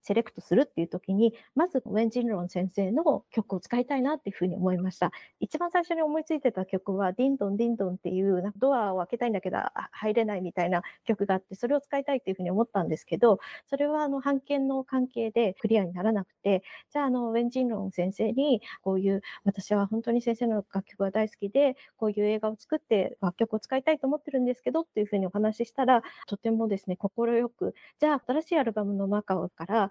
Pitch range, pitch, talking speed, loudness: 195-260 Hz, 220 Hz, 470 characters per minute, -28 LUFS